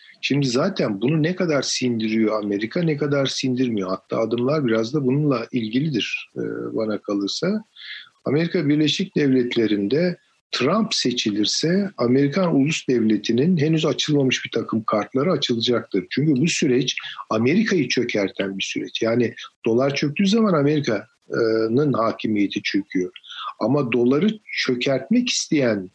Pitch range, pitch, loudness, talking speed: 115-155 Hz, 130 Hz, -21 LUFS, 115 wpm